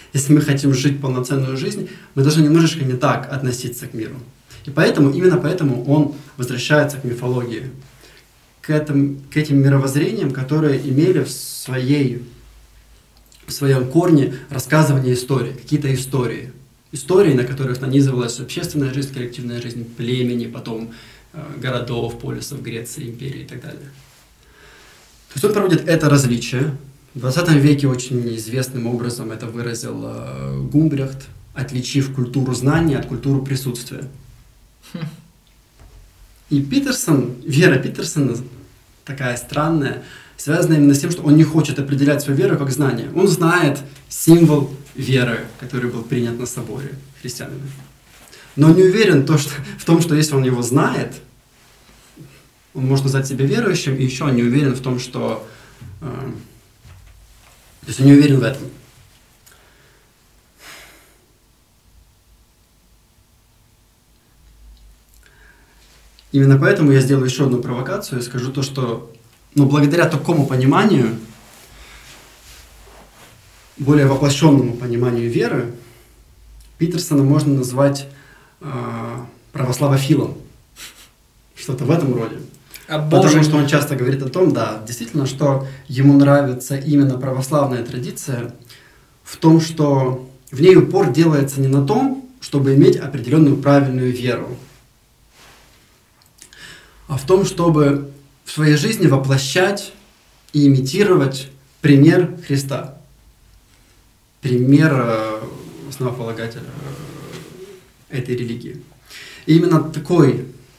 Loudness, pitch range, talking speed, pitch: -17 LUFS, 125-145 Hz, 115 wpm, 135 Hz